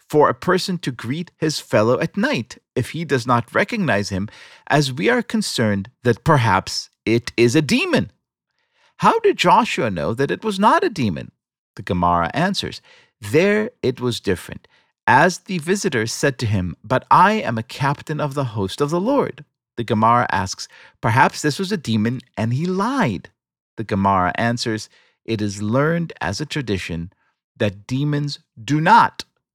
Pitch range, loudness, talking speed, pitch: 110-180 Hz, -19 LUFS, 170 wpm, 140 Hz